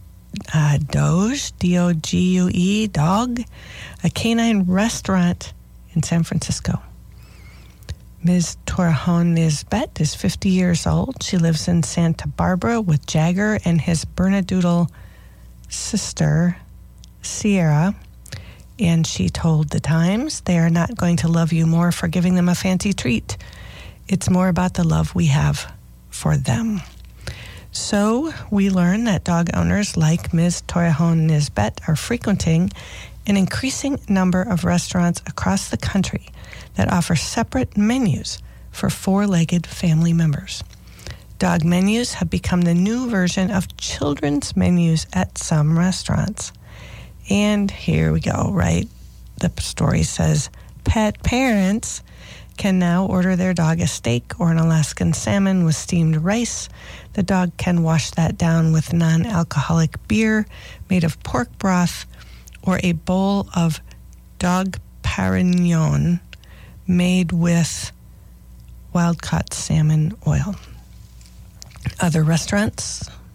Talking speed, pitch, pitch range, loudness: 125 wpm, 170 Hz, 150-185 Hz, -19 LUFS